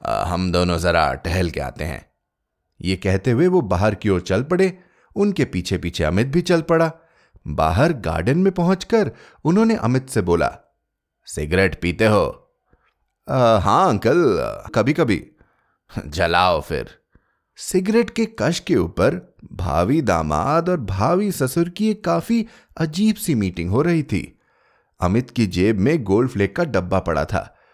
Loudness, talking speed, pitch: -20 LUFS, 150 wpm, 125 Hz